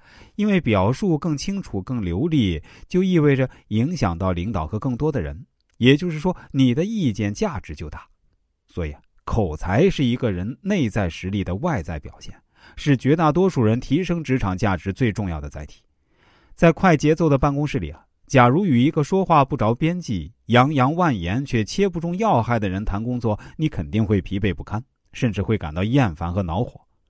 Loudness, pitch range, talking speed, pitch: -21 LUFS, 100-155 Hz, 280 characters per minute, 120 Hz